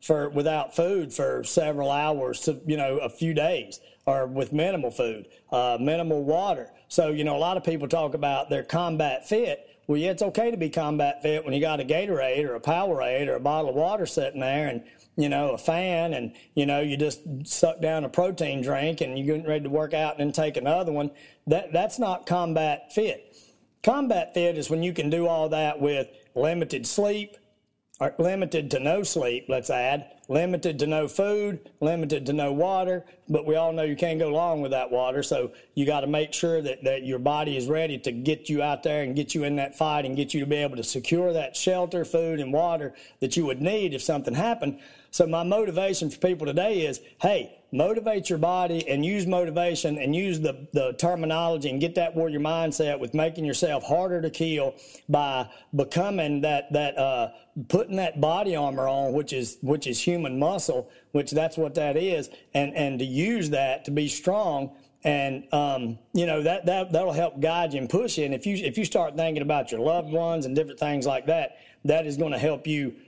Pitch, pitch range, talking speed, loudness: 155 Hz, 145-170 Hz, 215 wpm, -26 LUFS